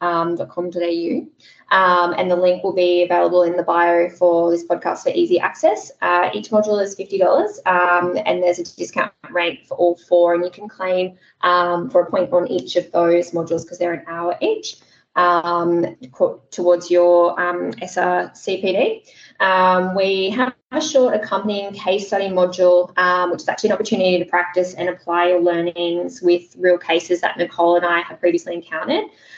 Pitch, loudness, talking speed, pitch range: 180 Hz, -18 LUFS, 175 wpm, 175-190 Hz